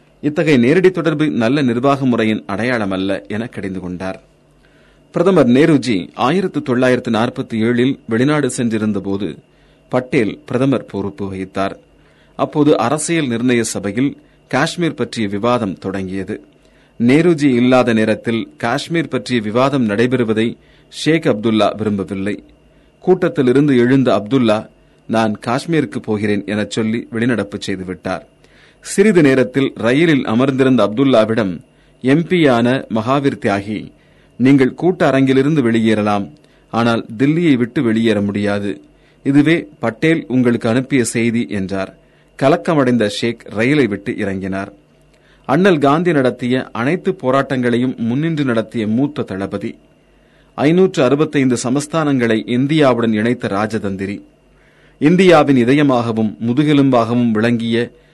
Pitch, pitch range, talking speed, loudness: 120 Hz, 105-140 Hz, 100 wpm, -15 LUFS